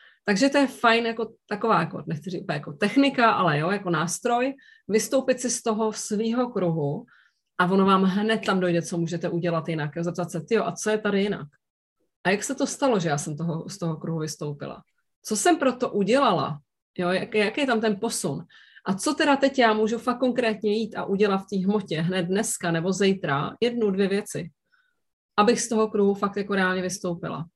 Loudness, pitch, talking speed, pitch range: -24 LUFS, 200 Hz, 200 wpm, 175-230 Hz